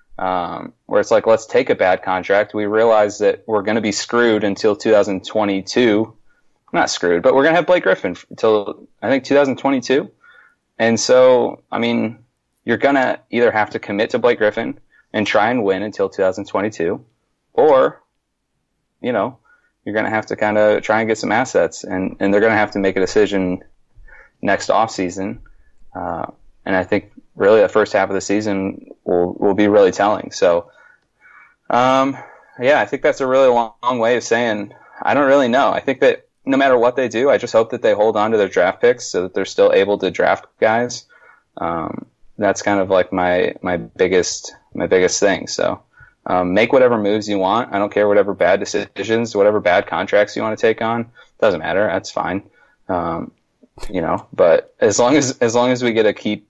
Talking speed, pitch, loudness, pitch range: 200 wpm, 110 Hz, -17 LUFS, 105-135 Hz